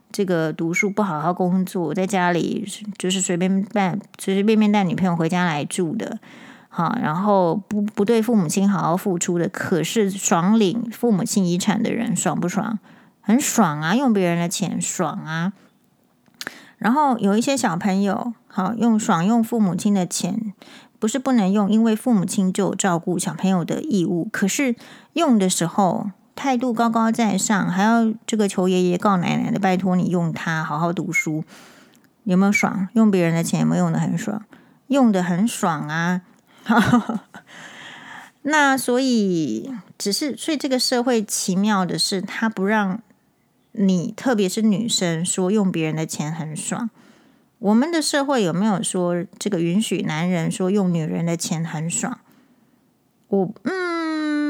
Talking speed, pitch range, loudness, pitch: 235 characters per minute, 185-230 Hz, -21 LUFS, 205 Hz